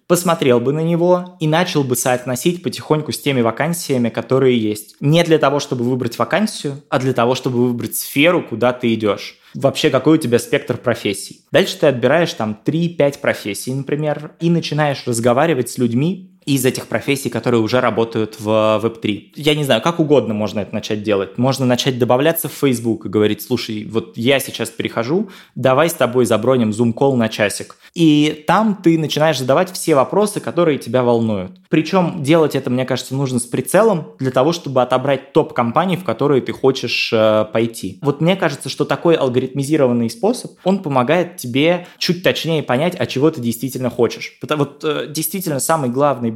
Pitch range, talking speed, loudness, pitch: 120-155 Hz, 175 wpm, -17 LUFS, 130 Hz